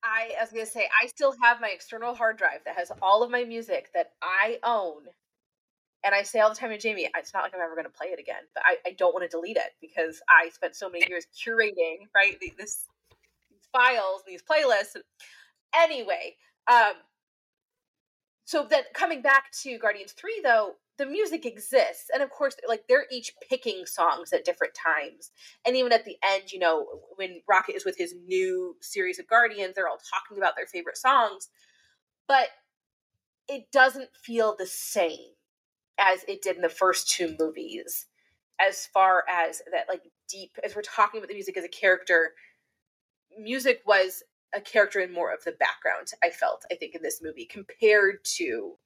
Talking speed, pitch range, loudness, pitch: 190 wpm, 190-300 Hz, -26 LUFS, 230 Hz